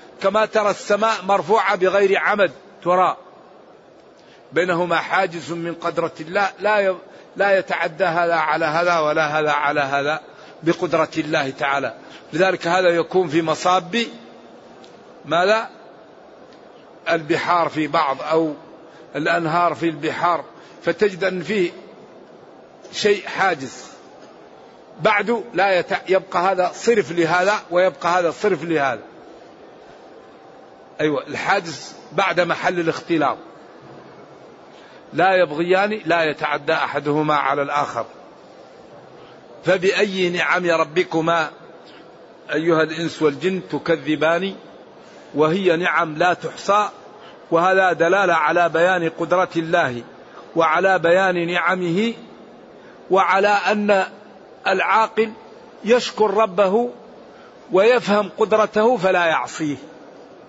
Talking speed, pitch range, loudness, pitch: 95 wpm, 160-195 Hz, -19 LUFS, 175 Hz